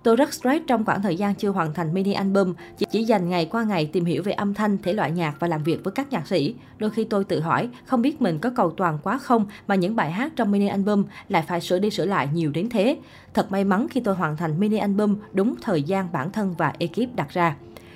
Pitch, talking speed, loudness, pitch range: 195 Hz, 265 wpm, -23 LUFS, 170-215 Hz